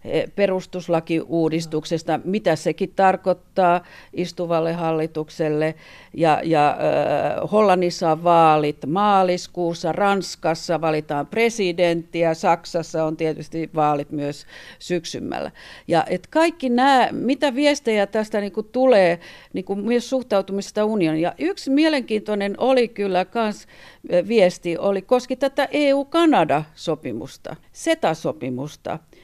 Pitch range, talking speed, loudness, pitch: 160-220 Hz, 90 wpm, -21 LUFS, 180 Hz